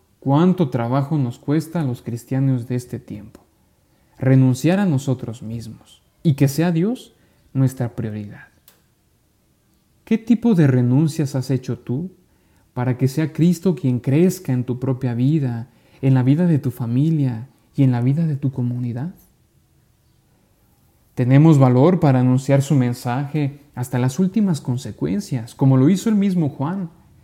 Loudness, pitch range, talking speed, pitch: -19 LUFS, 125-155 Hz, 145 wpm, 135 Hz